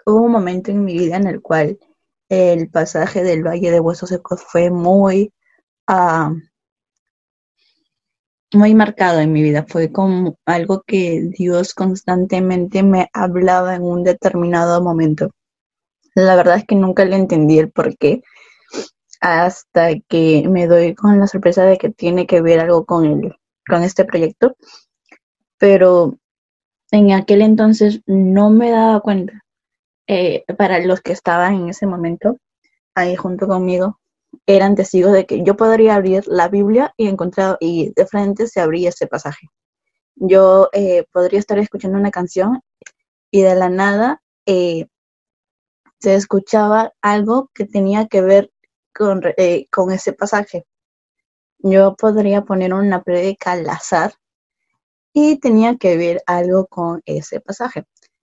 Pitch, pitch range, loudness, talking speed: 190 Hz, 175-205 Hz, -14 LUFS, 145 wpm